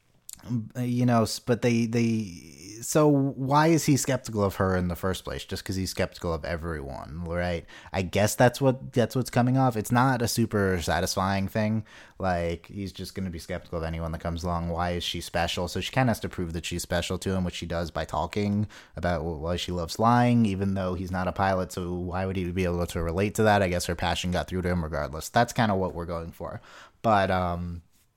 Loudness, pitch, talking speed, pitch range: -27 LUFS, 95 Hz, 230 wpm, 85-110 Hz